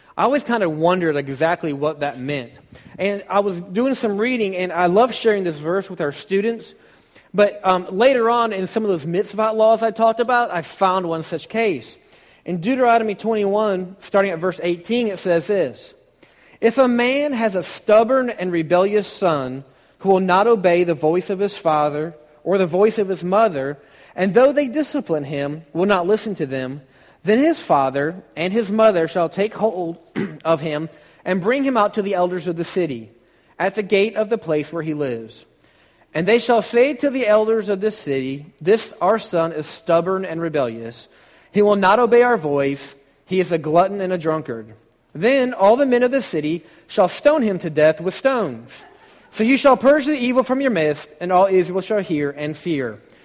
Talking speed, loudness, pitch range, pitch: 200 wpm, -19 LUFS, 160-220 Hz, 190 Hz